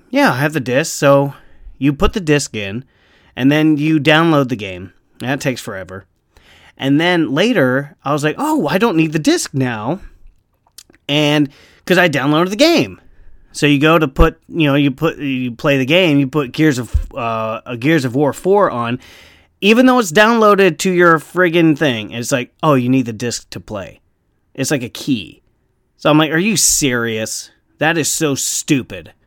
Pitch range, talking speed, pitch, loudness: 120-165 Hz, 190 wpm, 145 Hz, -15 LUFS